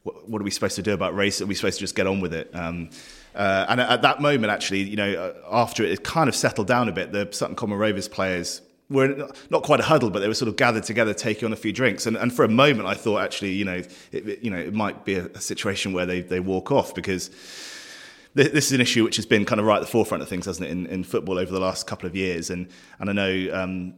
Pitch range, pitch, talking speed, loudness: 90-110 Hz, 100 Hz, 285 wpm, -23 LUFS